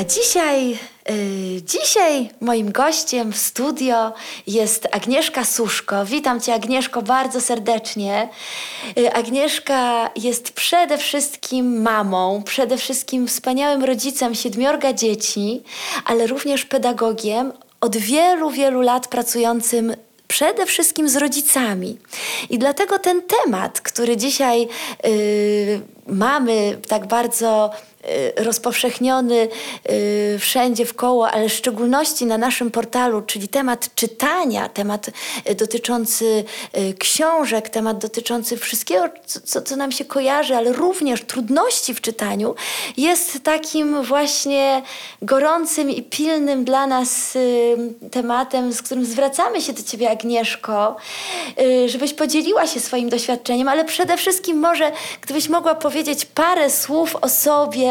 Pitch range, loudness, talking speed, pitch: 230-285 Hz, -19 LUFS, 120 wpm, 250 Hz